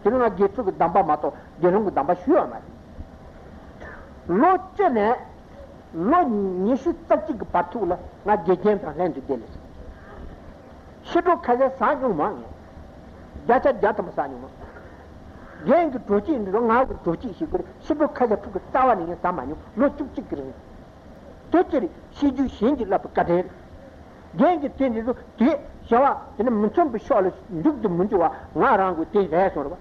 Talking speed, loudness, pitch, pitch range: 115 wpm, -22 LUFS, 235 Hz, 185-290 Hz